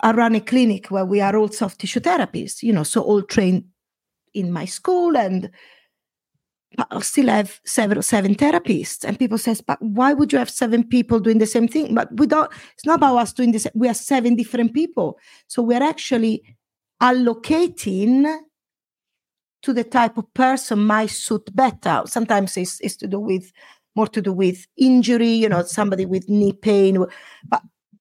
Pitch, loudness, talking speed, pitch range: 225 Hz, -19 LUFS, 185 wpm, 200-255 Hz